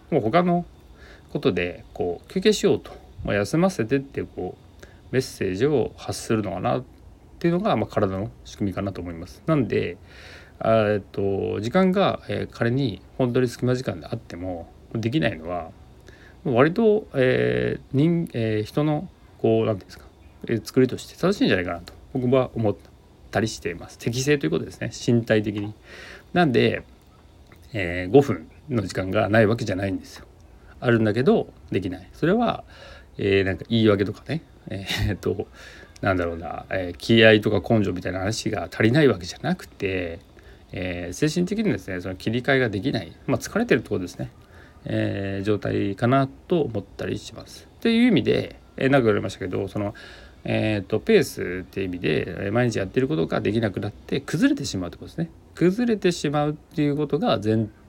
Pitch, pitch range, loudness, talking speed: 110 Hz, 95-130 Hz, -24 LUFS, 315 characters per minute